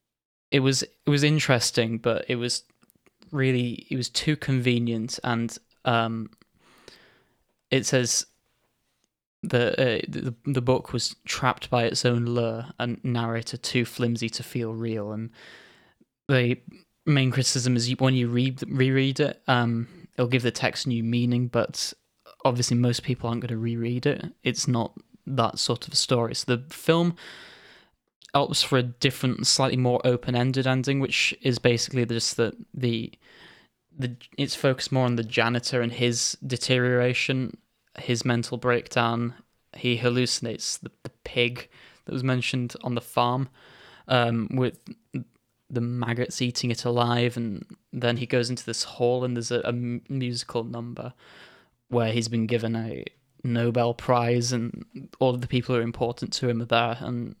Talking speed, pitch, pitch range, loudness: 155 wpm, 120 Hz, 120-130 Hz, -25 LUFS